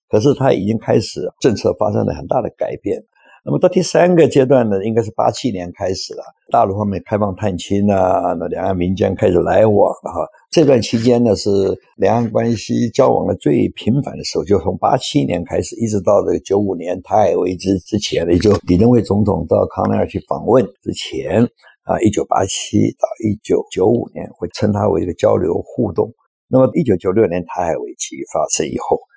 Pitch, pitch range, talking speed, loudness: 105 Hz, 95-120 Hz, 305 characters per minute, -16 LUFS